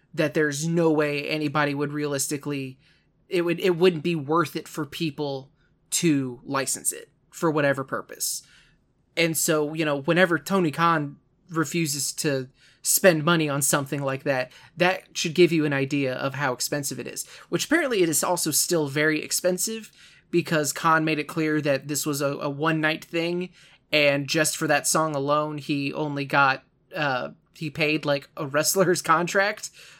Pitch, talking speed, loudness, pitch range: 155 Hz, 170 wpm, -24 LUFS, 145-165 Hz